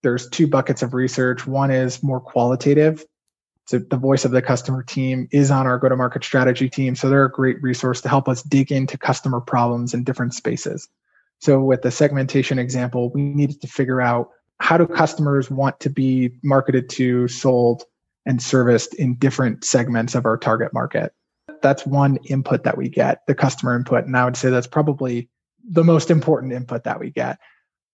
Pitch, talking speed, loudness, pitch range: 130 Hz, 190 wpm, -19 LUFS, 125-140 Hz